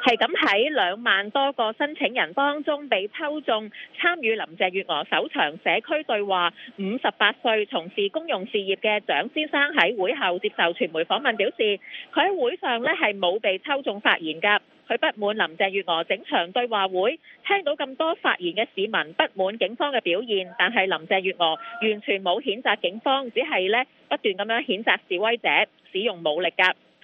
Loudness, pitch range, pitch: -23 LUFS, 200-310 Hz, 235 Hz